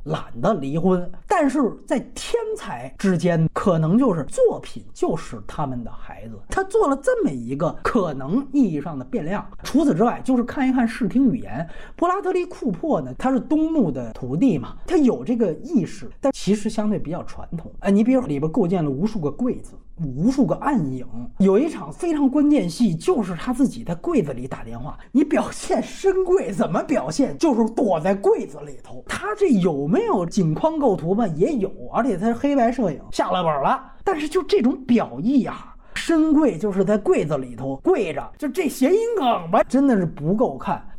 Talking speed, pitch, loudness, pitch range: 285 characters per minute, 235 Hz, -21 LUFS, 180-290 Hz